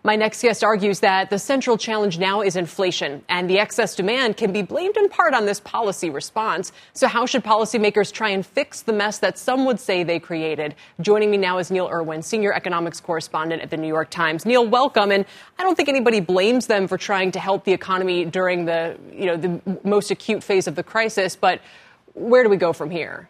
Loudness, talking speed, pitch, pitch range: -20 LUFS, 220 wpm, 200 Hz, 180-220 Hz